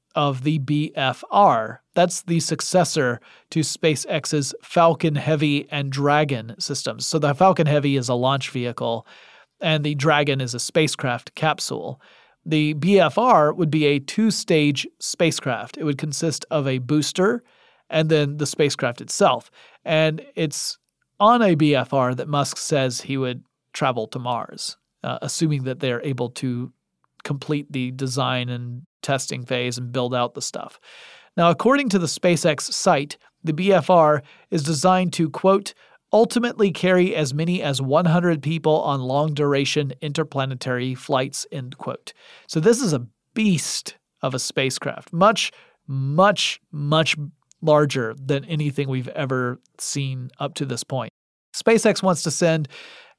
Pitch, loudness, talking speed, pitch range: 150 Hz, -21 LUFS, 145 wpm, 135-165 Hz